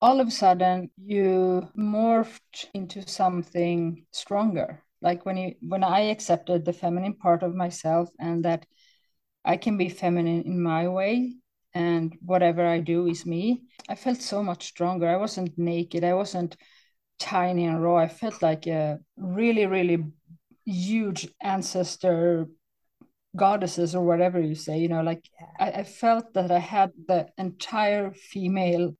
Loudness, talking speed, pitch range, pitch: -26 LUFS, 150 wpm, 170-195 Hz, 180 Hz